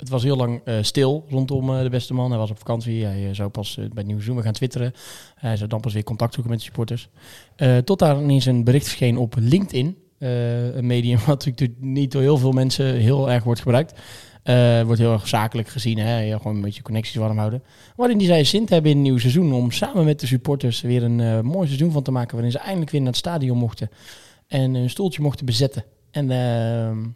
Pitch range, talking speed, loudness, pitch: 115-135 Hz, 245 wpm, -21 LUFS, 125 Hz